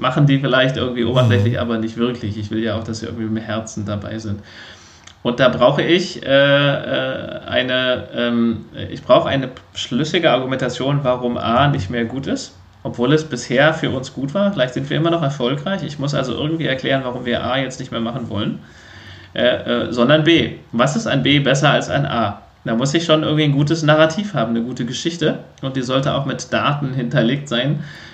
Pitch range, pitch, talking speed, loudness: 115-140 Hz, 125 Hz, 205 wpm, -18 LUFS